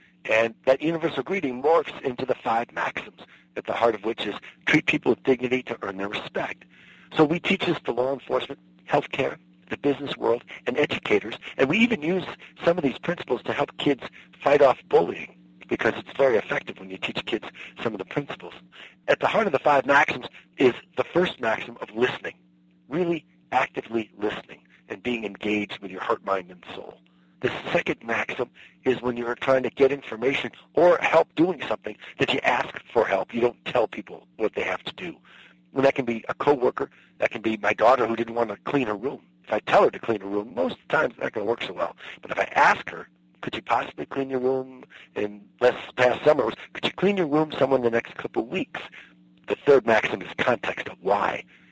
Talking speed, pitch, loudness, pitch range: 215 wpm, 115 Hz, -25 LUFS, 95-135 Hz